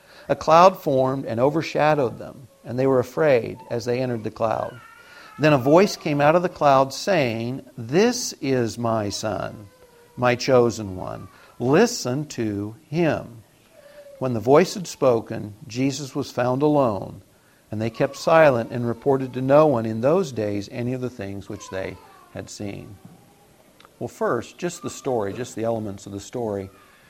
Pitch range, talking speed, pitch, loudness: 110-145 Hz, 165 wpm, 125 Hz, -22 LUFS